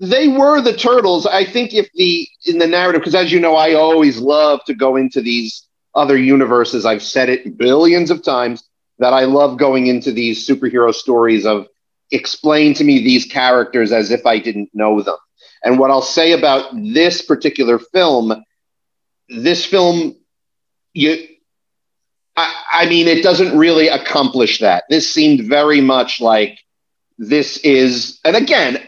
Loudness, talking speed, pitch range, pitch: -13 LUFS, 160 wpm, 125-175 Hz, 150 Hz